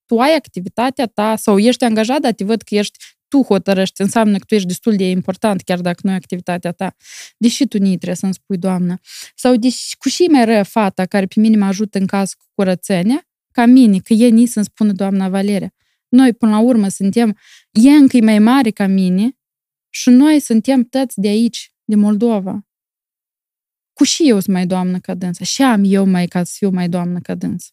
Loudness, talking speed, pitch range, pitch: -14 LUFS, 210 wpm, 190-235 Hz, 210 Hz